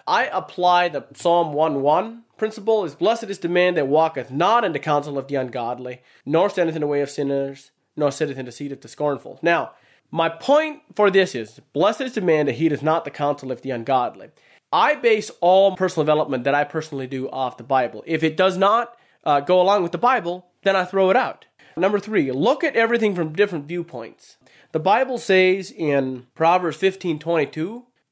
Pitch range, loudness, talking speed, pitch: 145-195 Hz, -21 LUFS, 205 wpm, 165 Hz